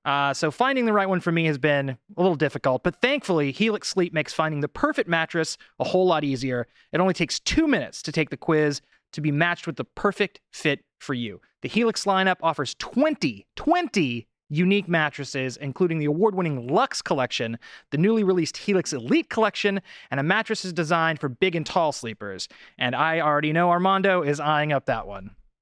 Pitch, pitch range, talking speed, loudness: 165 Hz, 145-190 Hz, 190 wpm, -24 LUFS